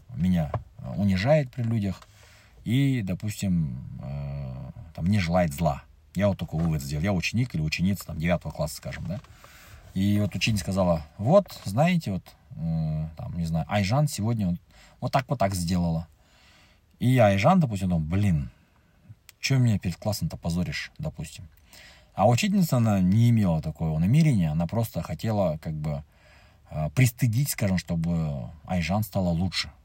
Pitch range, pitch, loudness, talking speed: 80-110 Hz, 95 Hz, -26 LUFS, 145 wpm